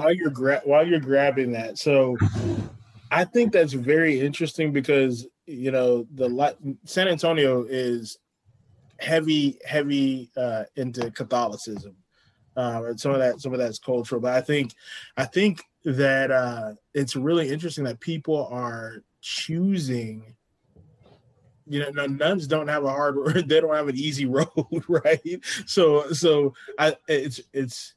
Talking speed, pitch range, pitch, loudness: 150 wpm, 125-155 Hz, 135 Hz, -24 LUFS